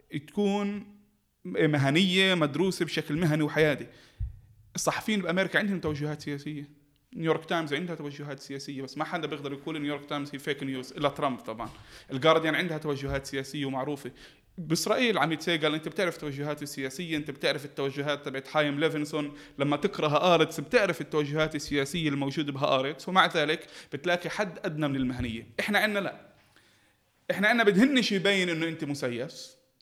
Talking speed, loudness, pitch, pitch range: 145 wpm, -28 LUFS, 150 Hz, 140-170 Hz